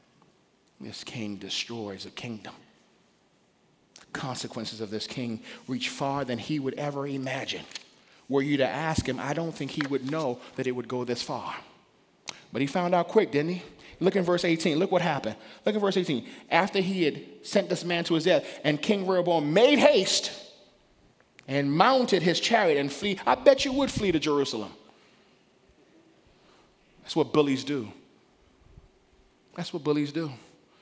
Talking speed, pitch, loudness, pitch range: 170 wpm, 145 Hz, -27 LUFS, 130-175 Hz